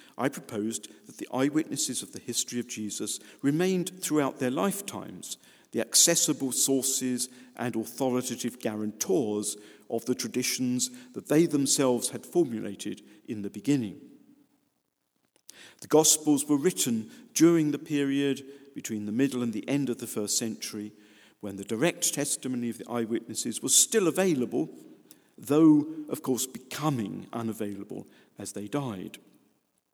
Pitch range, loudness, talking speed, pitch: 110-150 Hz, -27 LUFS, 130 wpm, 125 Hz